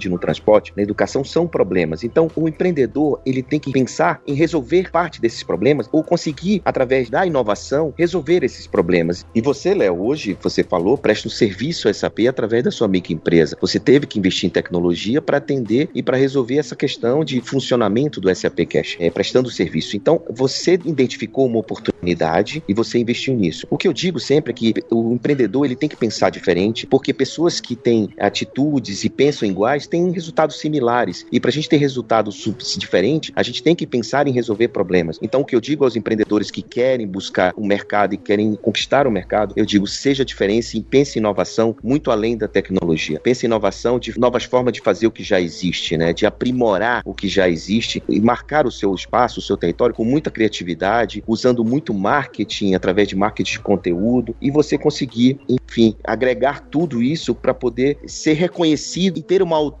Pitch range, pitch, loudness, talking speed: 100-140 Hz, 120 Hz, -18 LUFS, 195 wpm